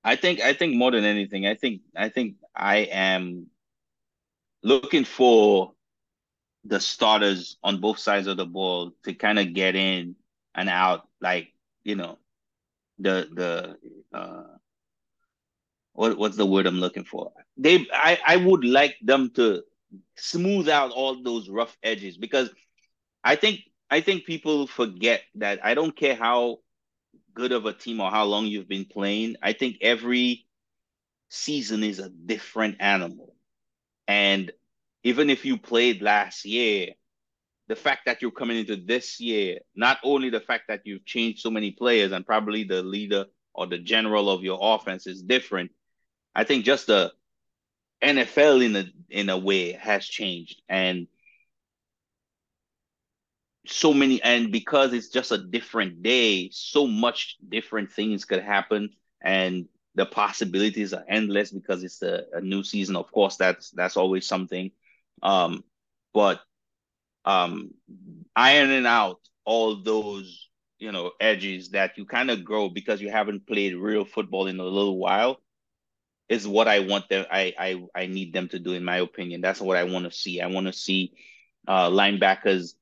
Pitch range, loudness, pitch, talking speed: 95-120 Hz, -24 LUFS, 105 Hz, 160 wpm